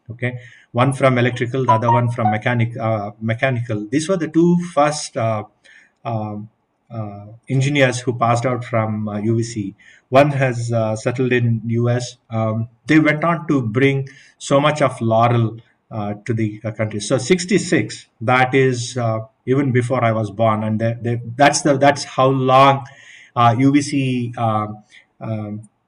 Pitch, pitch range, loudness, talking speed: 120 Hz, 110-135 Hz, -18 LUFS, 160 wpm